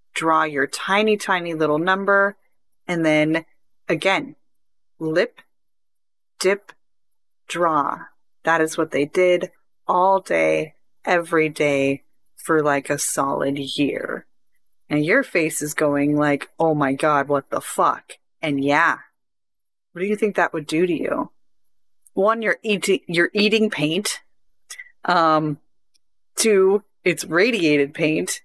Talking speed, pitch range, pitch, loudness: 125 wpm, 145-190 Hz, 160 Hz, -20 LUFS